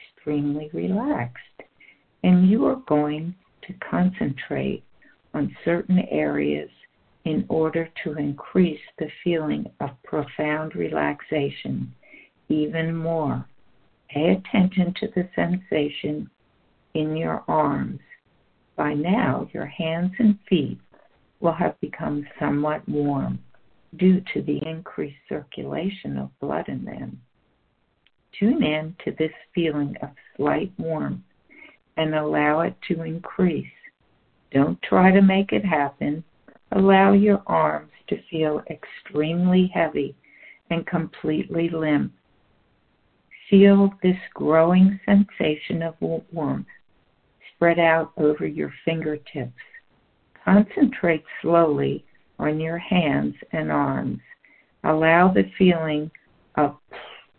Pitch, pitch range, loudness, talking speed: 160 Hz, 150-185 Hz, -23 LUFS, 105 wpm